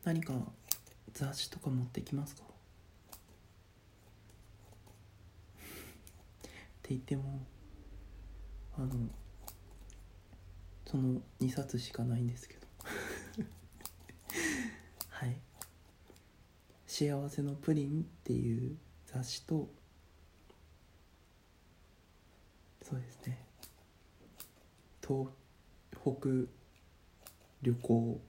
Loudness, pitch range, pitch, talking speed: -39 LUFS, 90-130 Hz, 105 Hz, 120 characters per minute